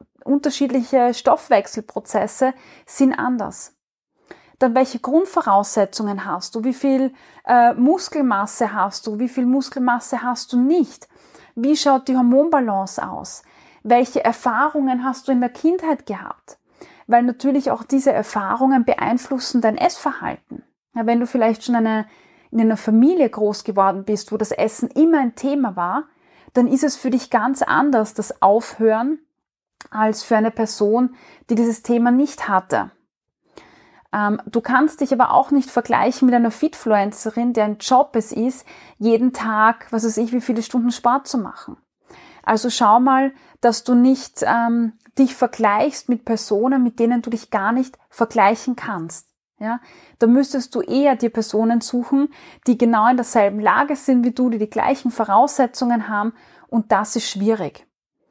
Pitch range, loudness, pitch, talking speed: 225-265 Hz, -19 LUFS, 245 Hz, 150 wpm